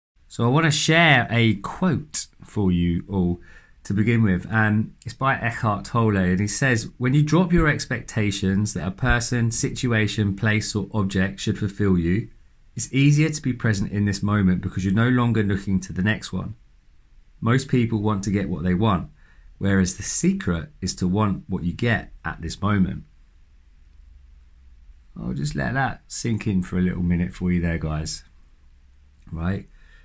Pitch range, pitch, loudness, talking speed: 85-115 Hz, 100 Hz, -22 LUFS, 175 wpm